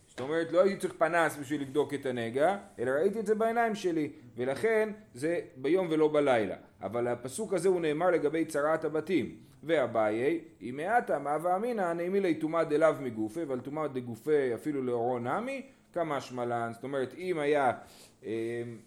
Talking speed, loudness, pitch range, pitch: 160 wpm, -31 LUFS, 130-180 Hz, 155 Hz